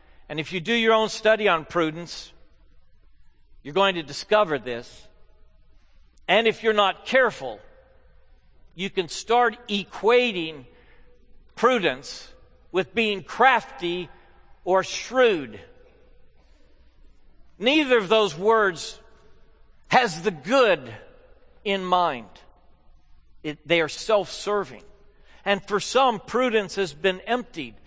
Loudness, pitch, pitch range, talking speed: -23 LUFS, 190 Hz, 145-220 Hz, 110 wpm